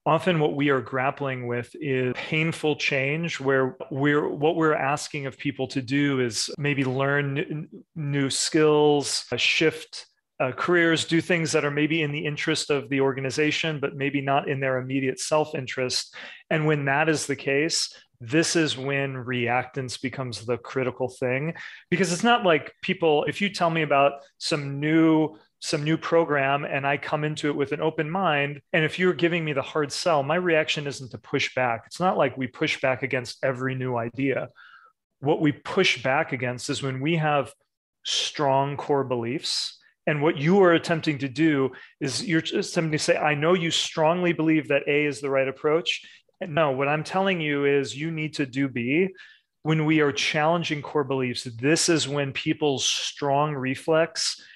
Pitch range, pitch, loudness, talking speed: 135-160 Hz, 145 Hz, -24 LUFS, 185 wpm